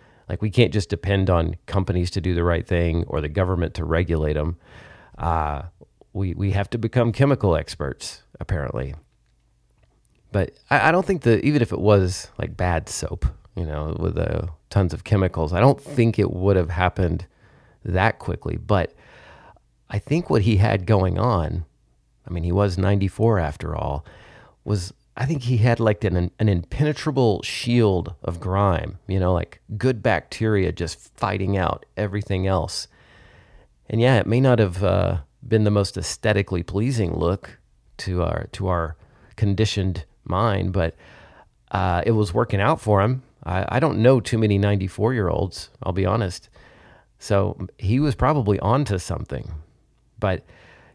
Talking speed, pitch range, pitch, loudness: 165 wpm, 90-115 Hz, 100 Hz, -22 LUFS